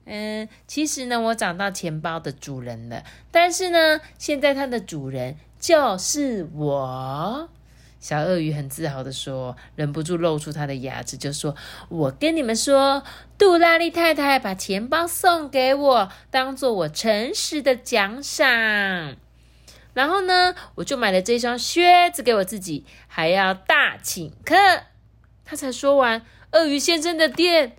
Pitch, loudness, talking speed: 230 Hz, -21 LUFS, 210 characters per minute